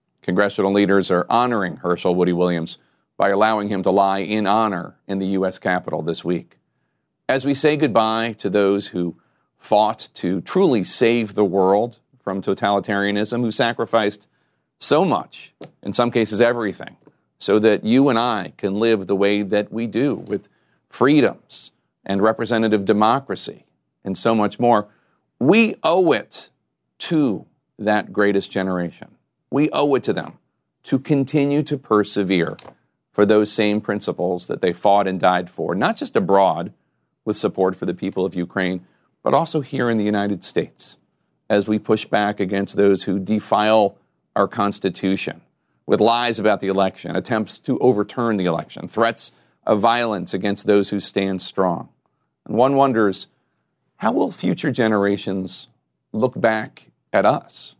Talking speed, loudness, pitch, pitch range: 150 wpm, -20 LUFS, 100 Hz, 95-110 Hz